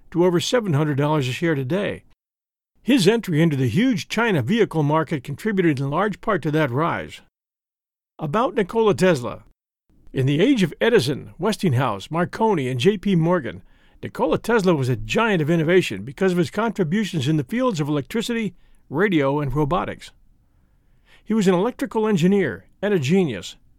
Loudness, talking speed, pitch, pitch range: -21 LUFS, 155 wpm, 175 Hz, 150-210 Hz